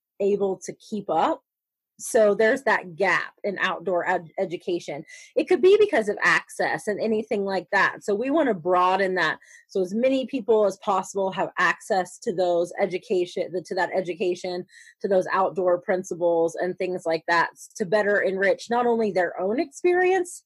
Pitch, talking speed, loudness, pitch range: 195 Hz, 175 wpm, -24 LUFS, 180-225 Hz